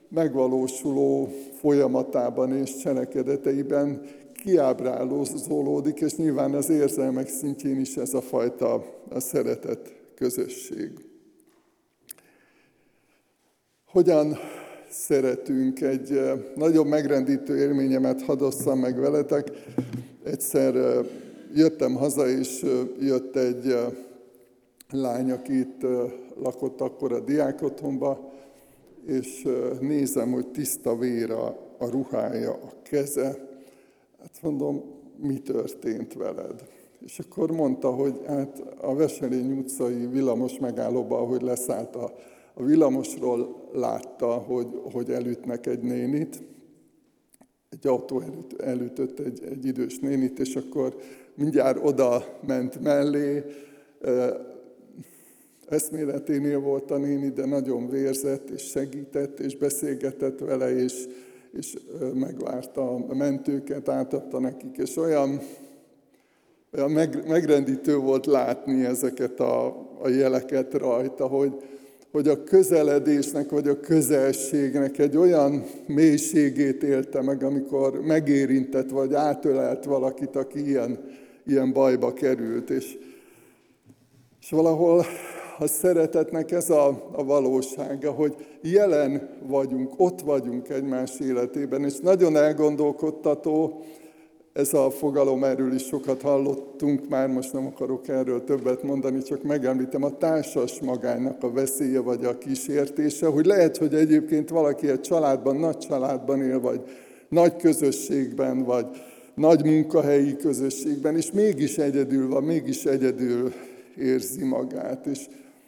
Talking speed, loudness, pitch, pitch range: 110 wpm, -25 LUFS, 140 Hz, 130-150 Hz